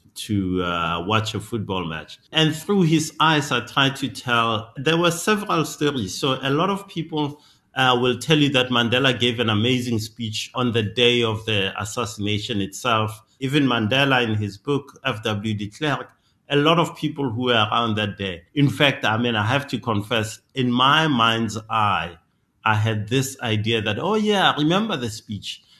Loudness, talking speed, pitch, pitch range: -21 LUFS, 185 wpm, 120 Hz, 110-140 Hz